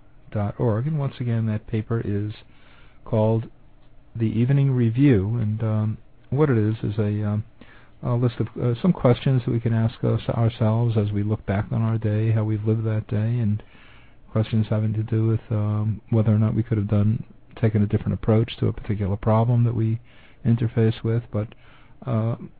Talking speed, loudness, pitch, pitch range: 190 wpm, -23 LUFS, 110 Hz, 110-120 Hz